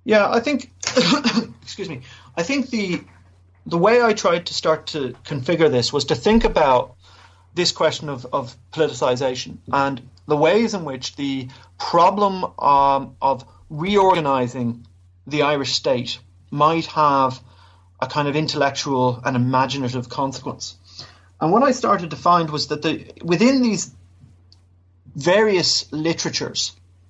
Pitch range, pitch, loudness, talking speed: 120-170 Hz, 140 Hz, -20 LUFS, 135 wpm